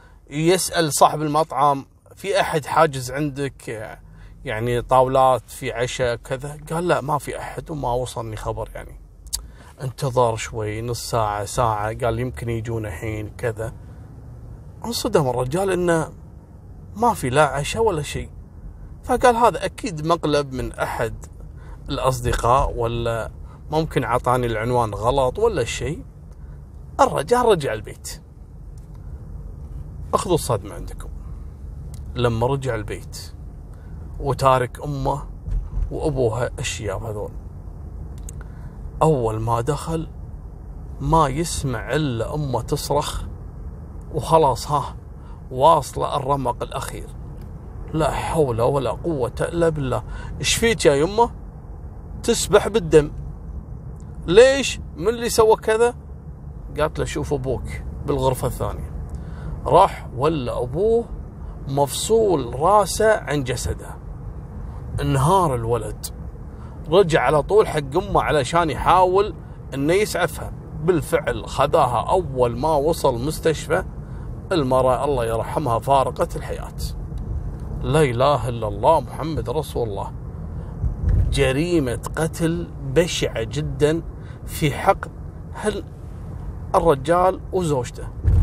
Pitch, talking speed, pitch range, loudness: 125 Hz, 100 wpm, 95-155 Hz, -21 LUFS